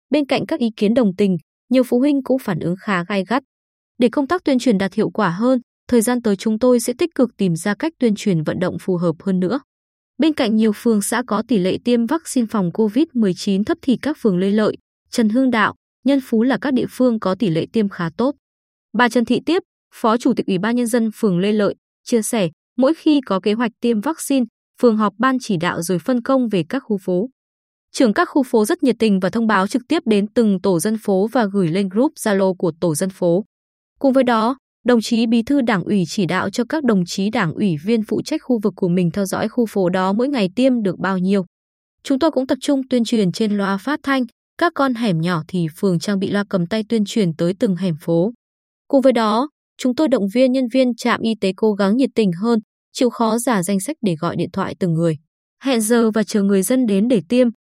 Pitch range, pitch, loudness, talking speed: 195-255 Hz, 225 Hz, -18 LUFS, 245 wpm